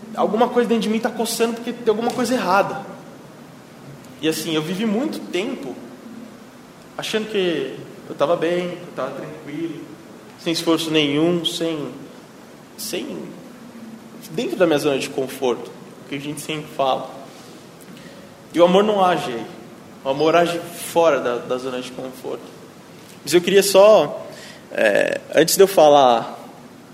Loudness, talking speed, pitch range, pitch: -19 LUFS, 145 wpm, 155-230 Hz, 180 Hz